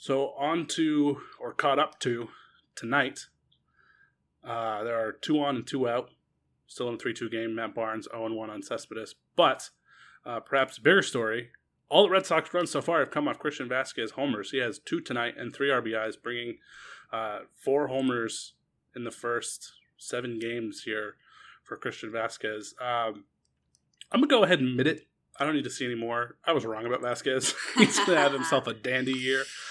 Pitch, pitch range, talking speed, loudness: 120 Hz, 115-140 Hz, 185 wpm, -28 LUFS